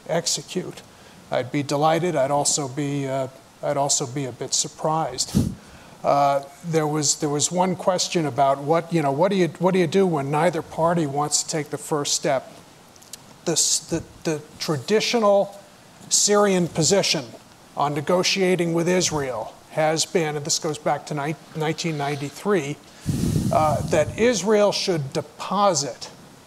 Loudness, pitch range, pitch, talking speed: -22 LUFS, 145-180 Hz, 160 Hz, 145 wpm